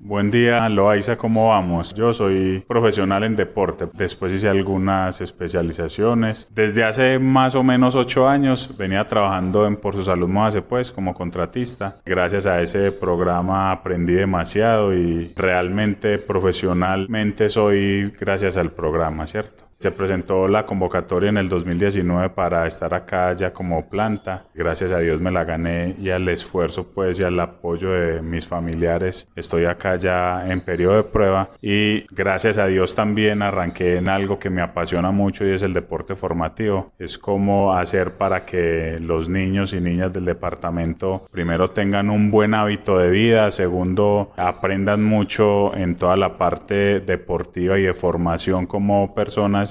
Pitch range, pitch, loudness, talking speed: 90-105 Hz, 95 Hz, -20 LUFS, 155 wpm